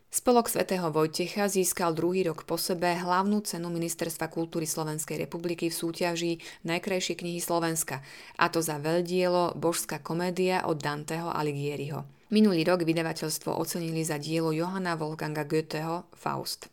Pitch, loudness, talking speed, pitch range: 170 Hz, -29 LUFS, 135 wpm, 160-175 Hz